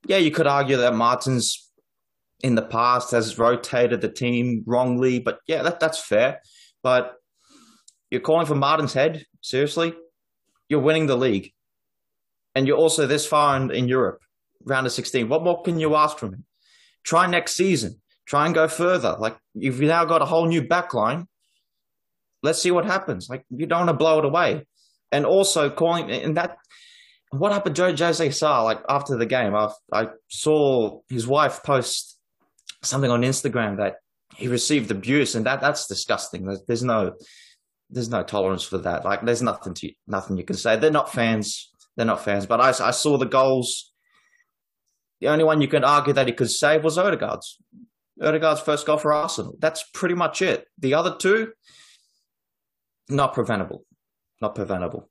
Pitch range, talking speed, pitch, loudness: 120-165 Hz, 175 wpm, 145 Hz, -22 LUFS